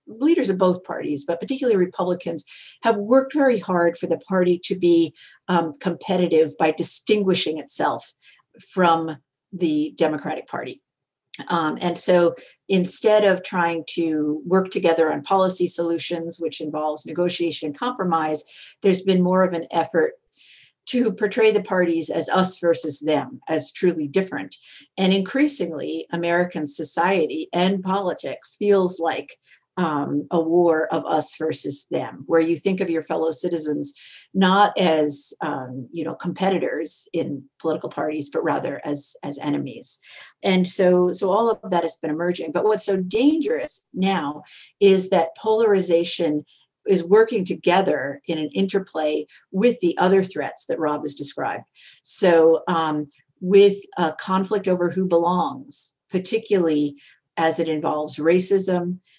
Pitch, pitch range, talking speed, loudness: 175 Hz, 160-190 Hz, 140 wpm, -21 LUFS